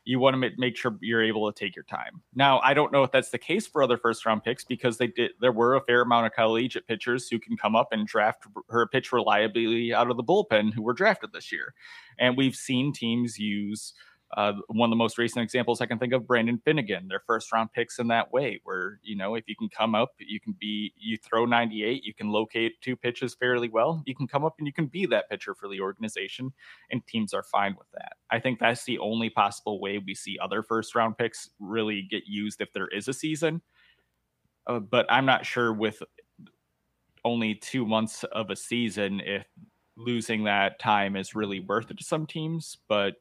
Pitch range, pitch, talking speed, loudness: 110-125 Hz, 115 Hz, 225 wpm, -27 LUFS